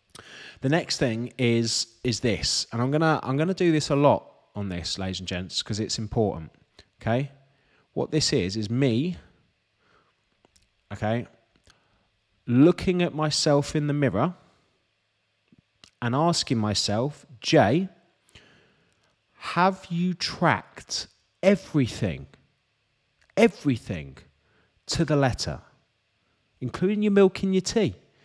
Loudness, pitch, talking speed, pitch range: -25 LUFS, 130 Hz, 120 wpm, 110-155 Hz